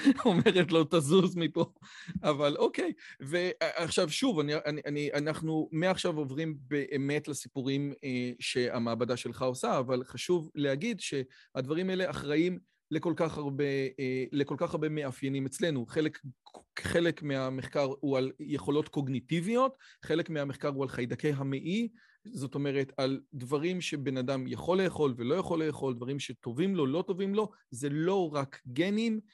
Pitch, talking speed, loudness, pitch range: 150 Hz, 140 wpm, -32 LUFS, 135-170 Hz